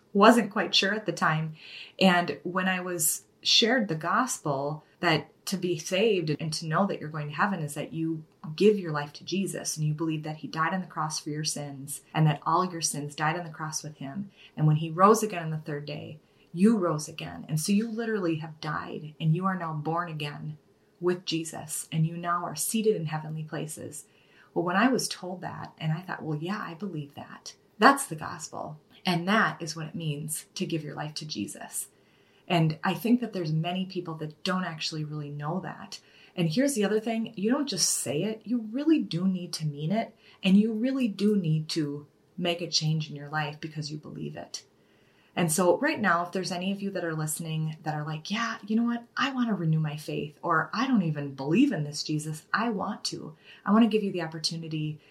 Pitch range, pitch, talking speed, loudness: 155-195 Hz, 165 Hz, 225 wpm, -28 LUFS